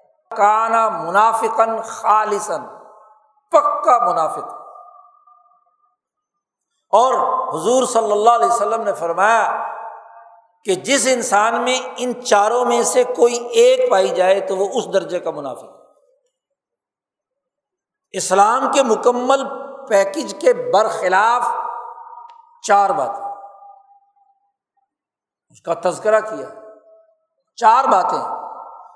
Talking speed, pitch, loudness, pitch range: 95 wpm, 240 Hz, -16 LUFS, 215-325 Hz